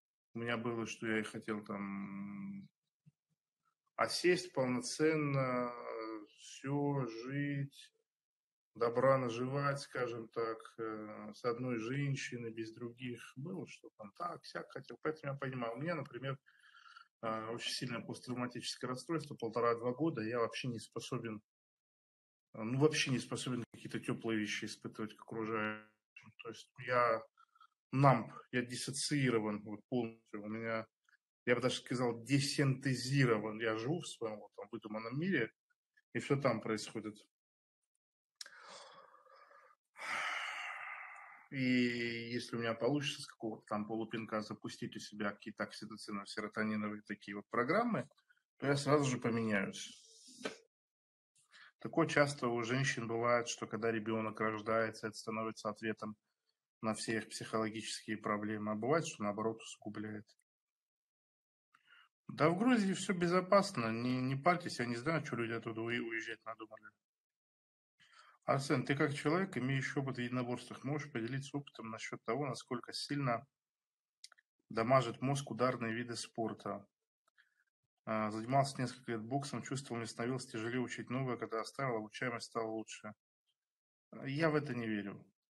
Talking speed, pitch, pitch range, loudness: 125 wpm, 120 Hz, 110-140 Hz, -38 LUFS